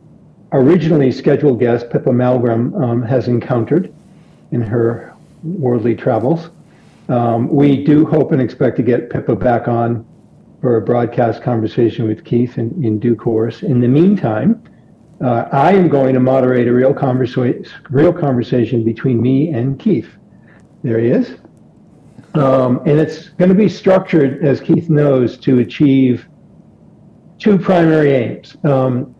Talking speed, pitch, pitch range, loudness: 145 wpm, 130 Hz, 120-155 Hz, -14 LUFS